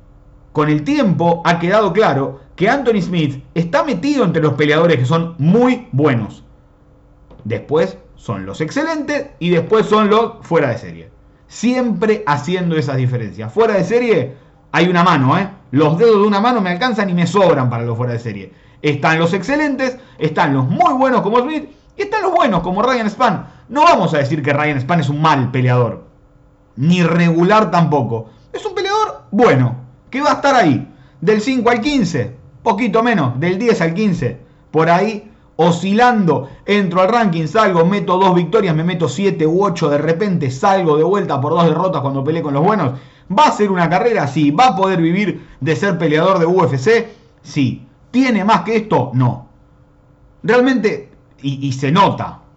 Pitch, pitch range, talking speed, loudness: 170 Hz, 145-220 Hz, 180 wpm, -15 LUFS